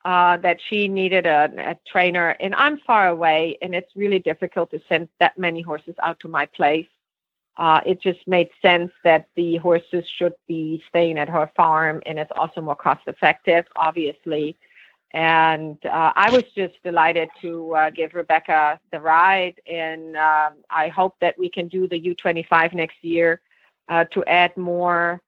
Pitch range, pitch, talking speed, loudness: 160-180 Hz, 170 Hz, 175 wpm, -20 LUFS